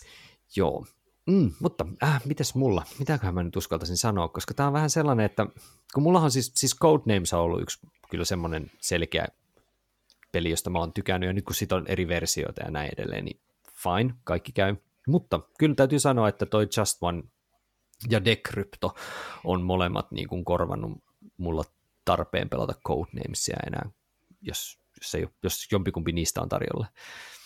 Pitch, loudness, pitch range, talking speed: 100 Hz, -27 LUFS, 85-130 Hz, 165 wpm